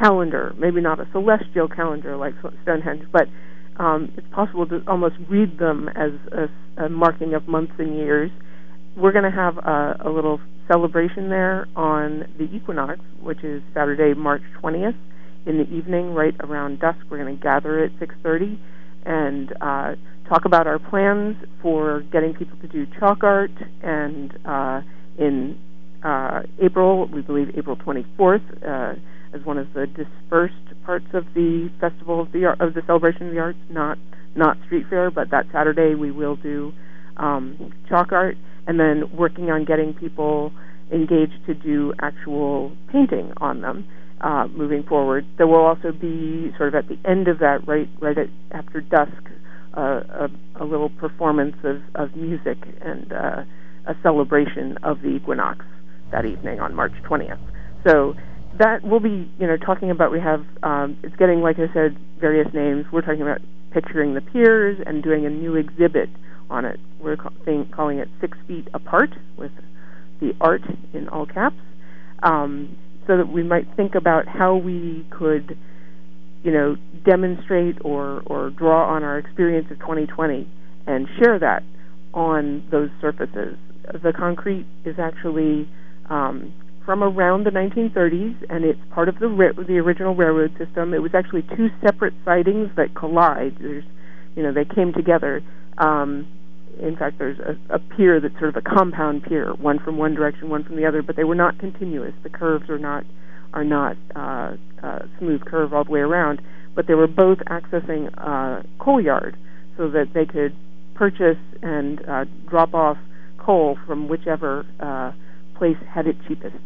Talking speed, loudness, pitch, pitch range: 170 wpm, -21 LUFS, 155 Hz, 145-175 Hz